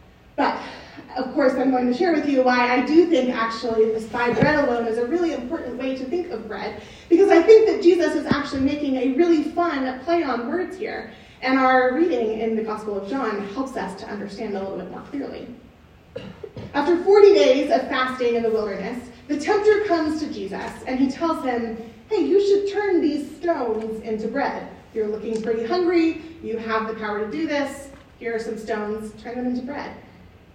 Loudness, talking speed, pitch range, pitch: -21 LUFS, 205 wpm, 230-325 Hz, 260 Hz